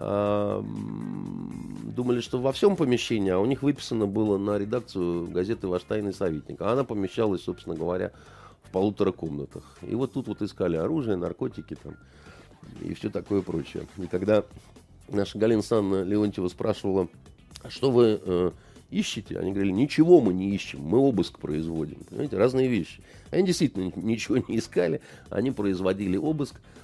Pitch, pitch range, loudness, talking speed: 105 Hz, 95-125 Hz, -27 LUFS, 150 wpm